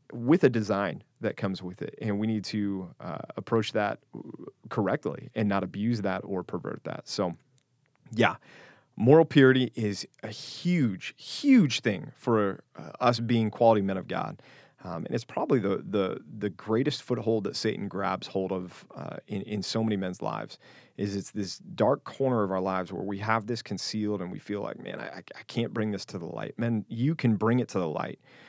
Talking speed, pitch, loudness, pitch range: 200 wpm, 110 Hz, -29 LUFS, 100-120 Hz